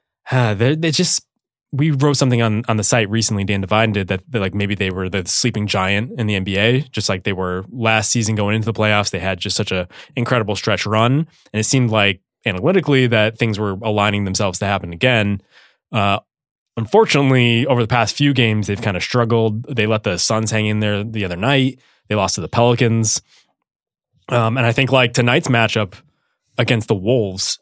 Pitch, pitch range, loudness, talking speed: 110 Hz, 105-125 Hz, -17 LUFS, 200 wpm